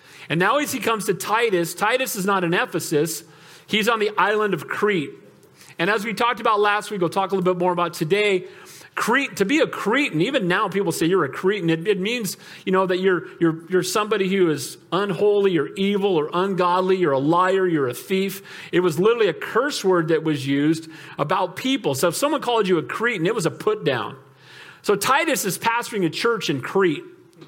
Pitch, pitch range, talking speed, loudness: 190 Hz, 170-210 Hz, 215 wpm, -21 LUFS